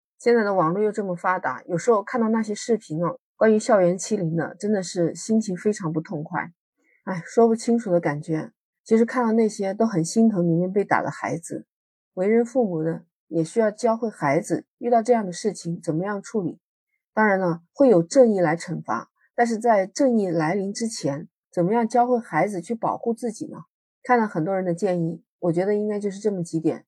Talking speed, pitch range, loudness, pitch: 305 characters per minute, 170-225 Hz, -23 LUFS, 200 Hz